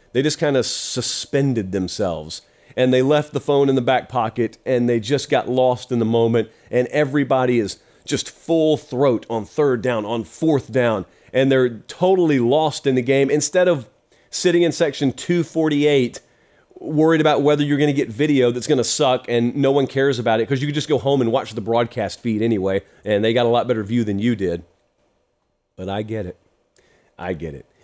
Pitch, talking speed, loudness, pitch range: 130 Hz, 205 wpm, -19 LUFS, 115-145 Hz